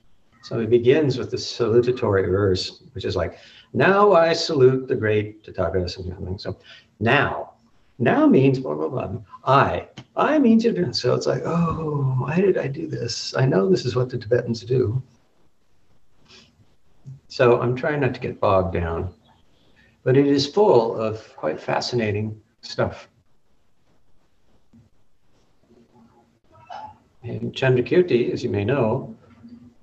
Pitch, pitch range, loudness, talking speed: 120 Hz, 110-135 Hz, -21 LUFS, 130 wpm